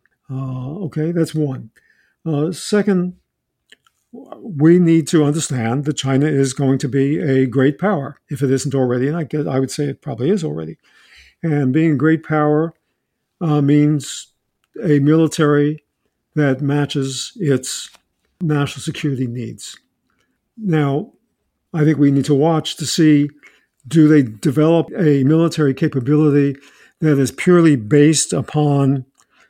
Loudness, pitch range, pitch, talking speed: -17 LUFS, 135-160 Hz, 145 Hz, 135 wpm